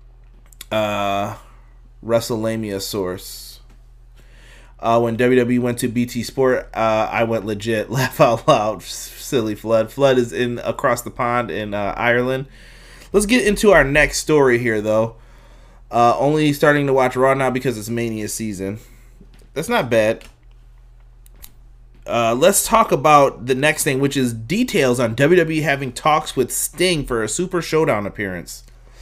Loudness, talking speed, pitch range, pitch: -18 LUFS, 150 wpm, 115-135 Hz, 120 Hz